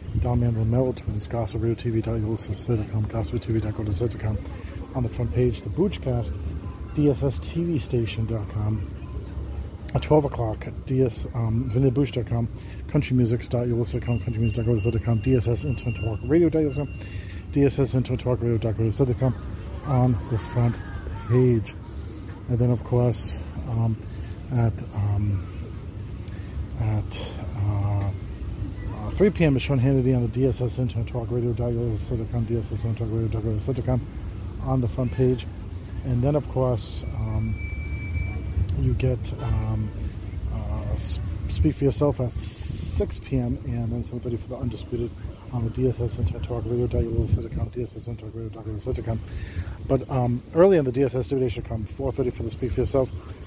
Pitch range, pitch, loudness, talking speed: 100-125 Hz, 115 Hz, -26 LUFS, 115 wpm